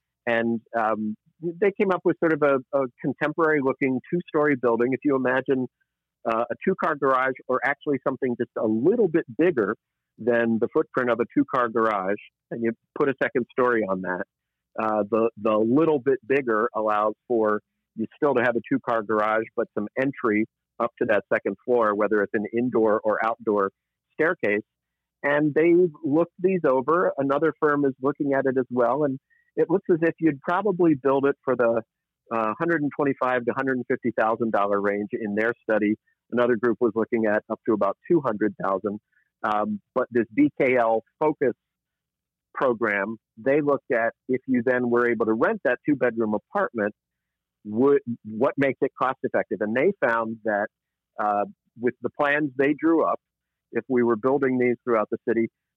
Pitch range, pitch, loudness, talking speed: 110-140 Hz, 125 Hz, -24 LUFS, 170 wpm